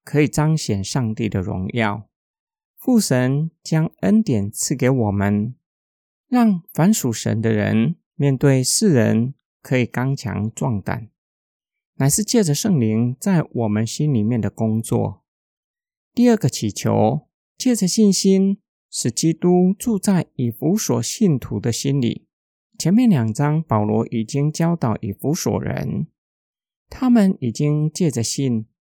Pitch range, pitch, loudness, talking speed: 110-180 Hz, 135 Hz, -19 LUFS, 190 characters per minute